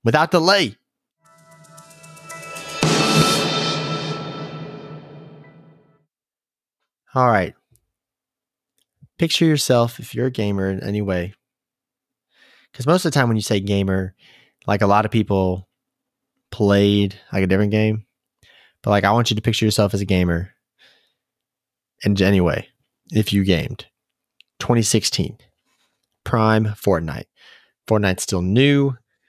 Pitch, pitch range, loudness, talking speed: 110 Hz, 100-145 Hz, -19 LUFS, 110 wpm